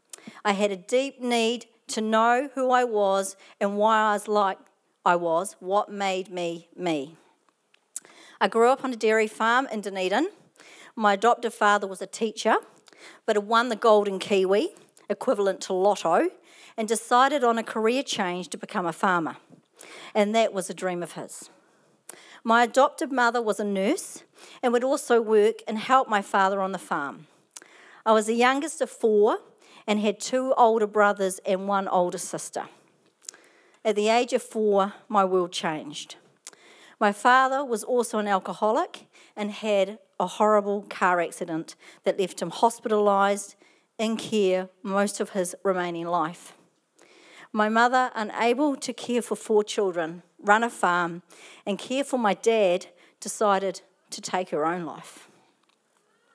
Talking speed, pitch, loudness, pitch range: 155 wpm, 210 Hz, -25 LUFS, 195-235 Hz